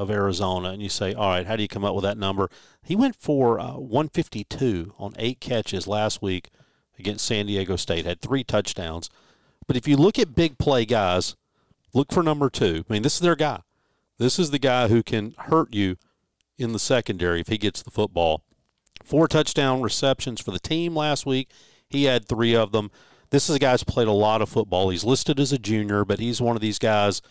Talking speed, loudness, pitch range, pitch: 220 wpm, -23 LUFS, 100-135 Hz, 110 Hz